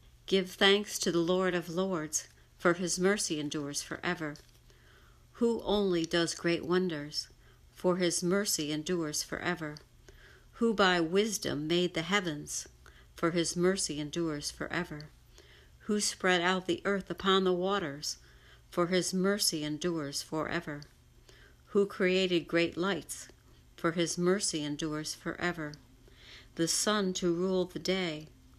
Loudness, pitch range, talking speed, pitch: -31 LUFS, 150-185 Hz, 130 wpm, 170 Hz